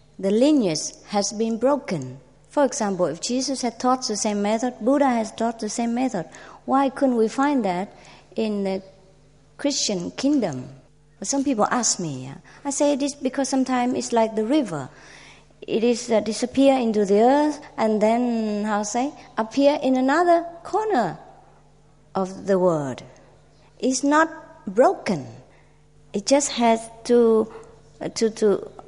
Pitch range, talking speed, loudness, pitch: 205-275 Hz, 150 wpm, -22 LUFS, 230 Hz